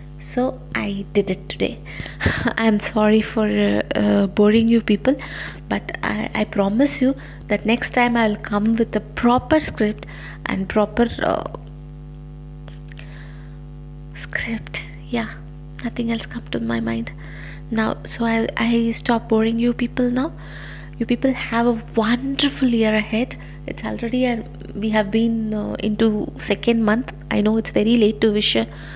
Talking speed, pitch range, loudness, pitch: 155 wpm, 150-235 Hz, -20 LUFS, 215 Hz